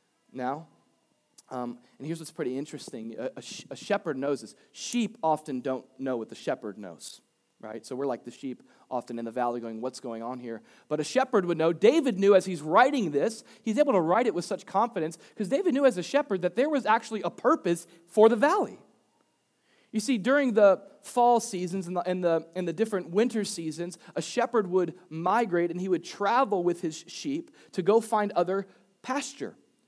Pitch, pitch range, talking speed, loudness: 180 Hz, 155-225 Hz, 205 wpm, -28 LUFS